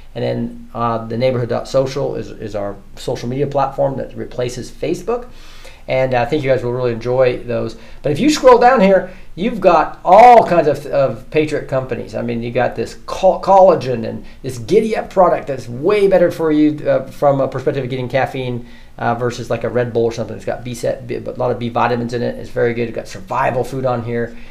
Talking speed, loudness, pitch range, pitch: 215 wpm, -16 LUFS, 120-155 Hz, 130 Hz